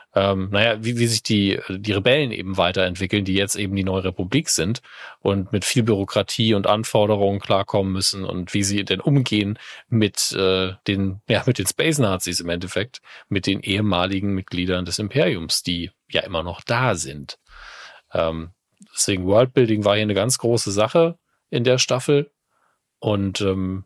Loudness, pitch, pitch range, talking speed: -21 LUFS, 100 Hz, 95-115 Hz, 165 wpm